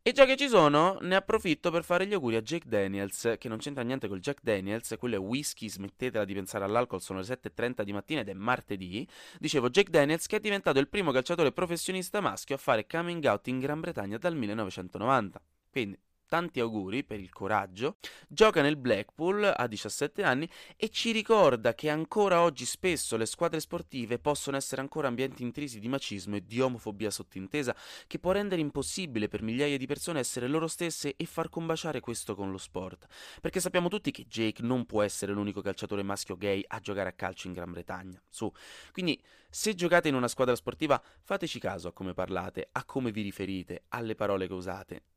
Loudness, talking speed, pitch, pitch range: -31 LUFS, 195 wpm, 125 Hz, 100-165 Hz